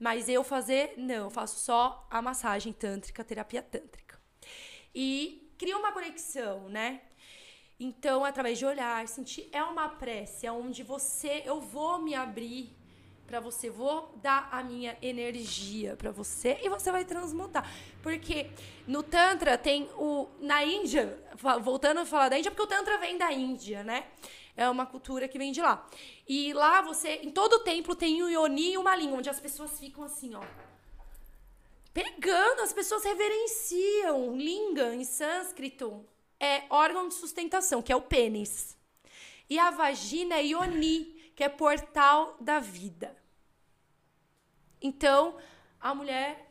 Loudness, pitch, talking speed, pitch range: -30 LUFS, 285 Hz, 155 wpm, 250-330 Hz